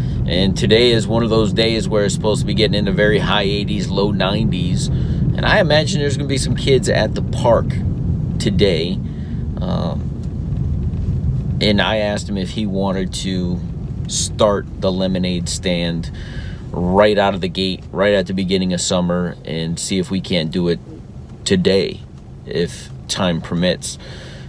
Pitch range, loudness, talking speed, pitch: 90-100 Hz, -18 LUFS, 165 wpm, 95 Hz